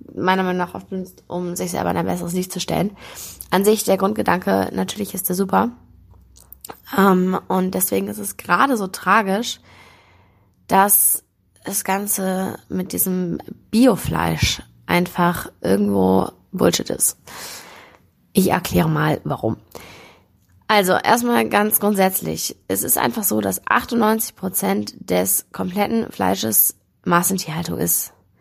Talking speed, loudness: 125 wpm, -19 LUFS